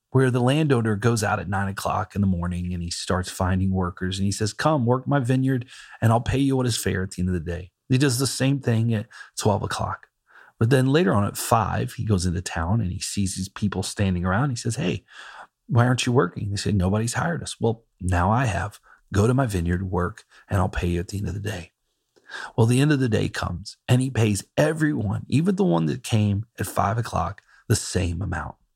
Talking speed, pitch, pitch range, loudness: 240 wpm, 105 Hz, 95-125 Hz, -24 LUFS